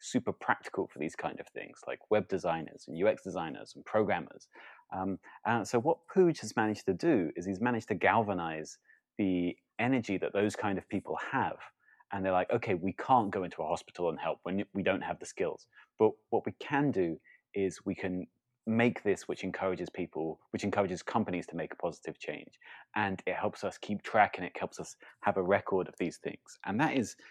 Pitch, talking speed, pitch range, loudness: 100 Hz, 210 wpm, 95-115 Hz, -33 LUFS